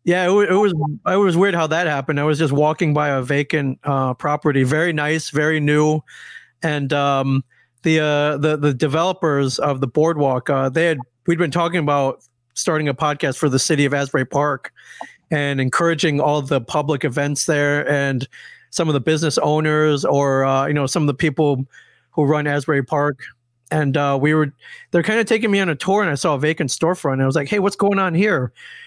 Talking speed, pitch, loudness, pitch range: 210 wpm, 150 Hz, -18 LUFS, 140-165 Hz